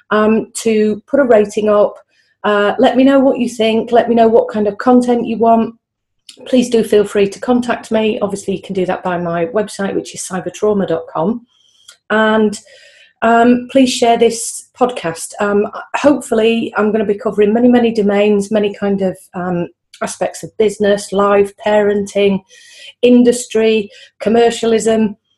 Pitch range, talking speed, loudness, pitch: 200-235 Hz, 160 wpm, -14 LUFS, 215 Hz